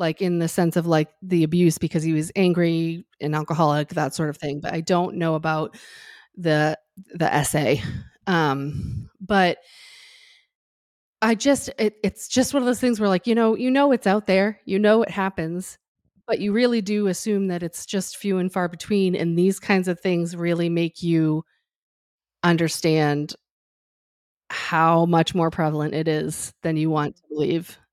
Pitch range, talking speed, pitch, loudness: 160-200 Hz, 175 wpm, 170 Hz, -22 LUFS